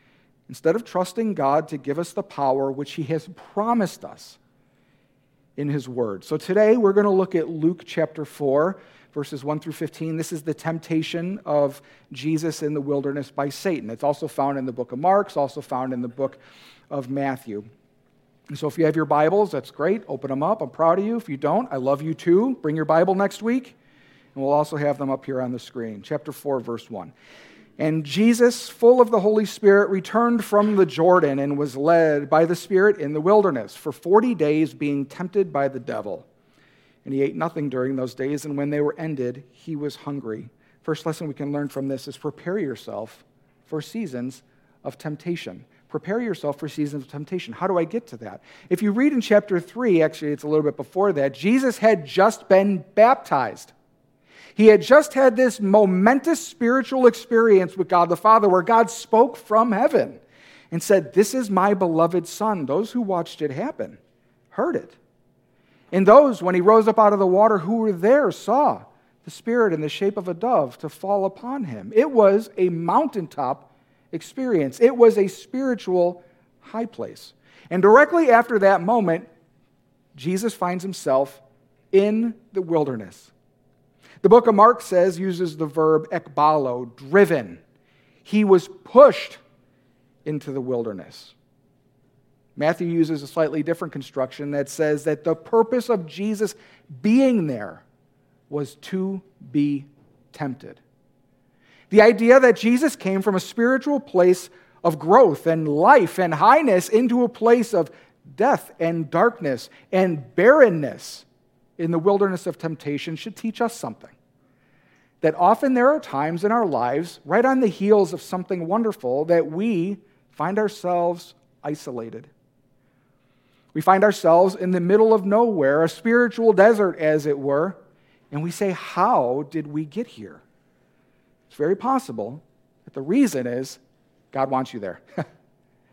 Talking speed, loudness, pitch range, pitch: 170 wpm, -20 LUFS, 140-205 Hz, 165 Hz